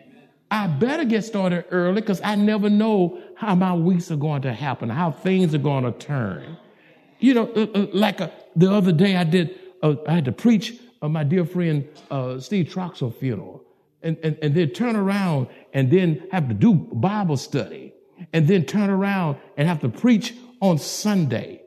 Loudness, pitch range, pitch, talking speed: -22 LUFS, 150-200 Hz, 180 Hz, 185 wpm